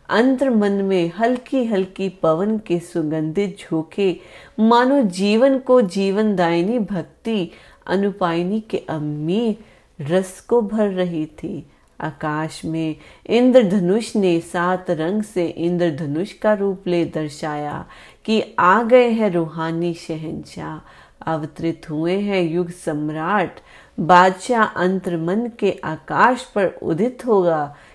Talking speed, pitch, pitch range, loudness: 90 wpm, 185 Hz, 165-215 Hz, -19 LUFS